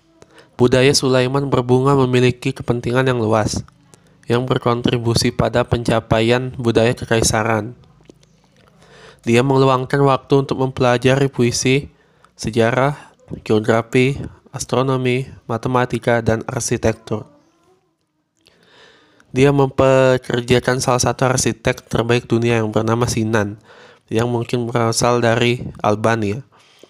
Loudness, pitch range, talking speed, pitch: -17 LUFS, 115-130 Hz, 90 wpm, 125 Hz